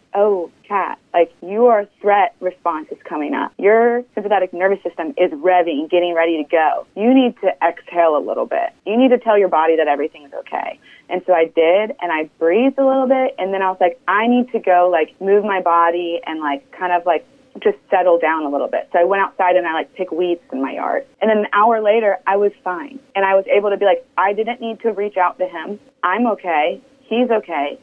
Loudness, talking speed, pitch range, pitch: -17 LUFS, 235 wpm, 175-225 Hz, 195 Hz